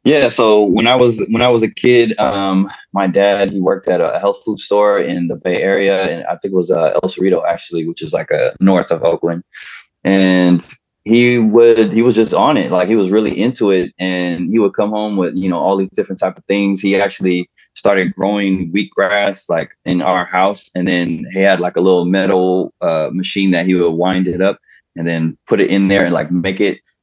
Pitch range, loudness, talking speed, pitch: 90-100 Hz, -14 LUFS, 230 wpm, 95 Hz